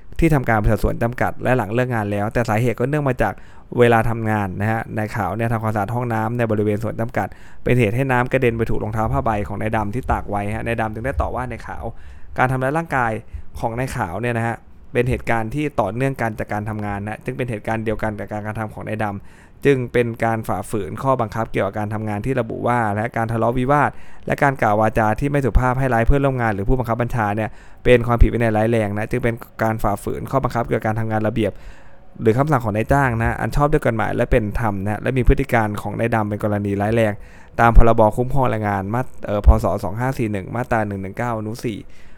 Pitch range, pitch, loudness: 105-120 Hz, 115 Hz, -20 LUFS